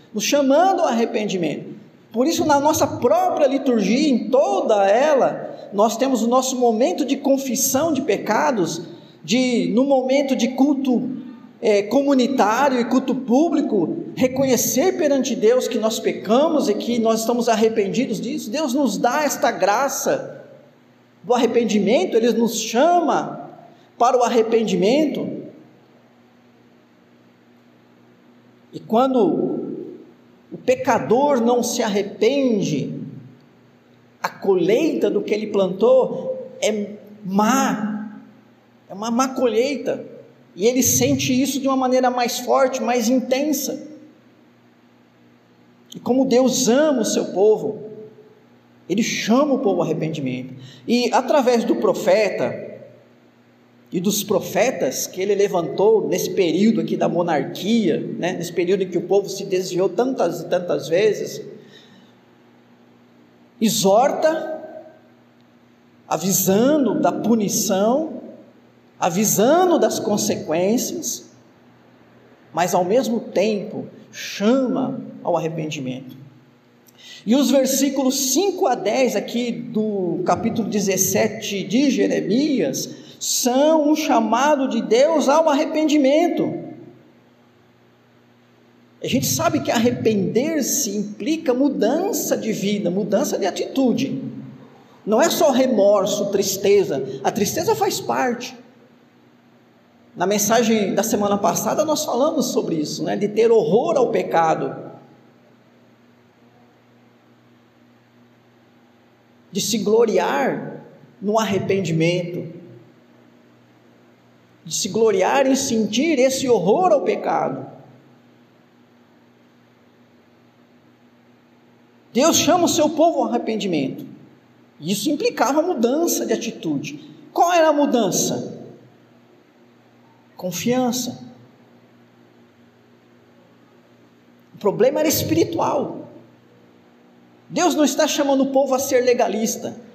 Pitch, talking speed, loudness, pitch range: 230 Hz, 105 wpm, -19 LUFS, 175-270 Hz